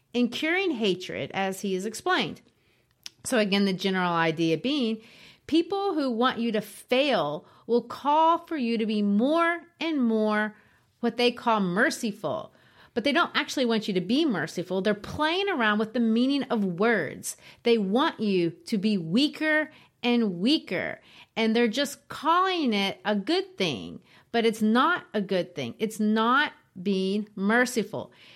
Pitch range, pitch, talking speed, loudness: 205-280 Hz, 230 Hz, 160 wpm, -26 LUFS